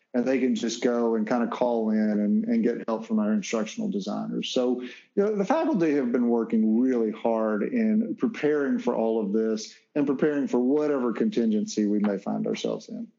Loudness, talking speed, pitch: -26 LUFS, 200 wpm, 125 Hz